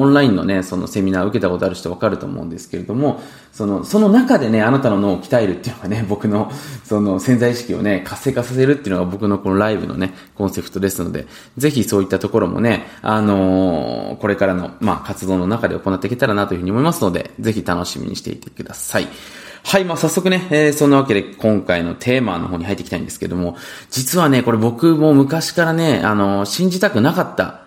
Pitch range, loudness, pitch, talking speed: 95-135 Hz, -17 LUFS, 105 Hz, 465 characters per minute